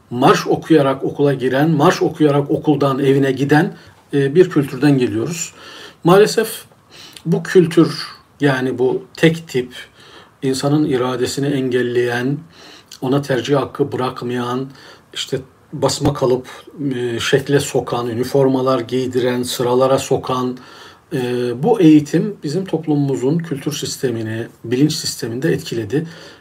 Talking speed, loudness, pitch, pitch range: 100 wpm, -17 LUFS, 135 Hz, 125-150 Hz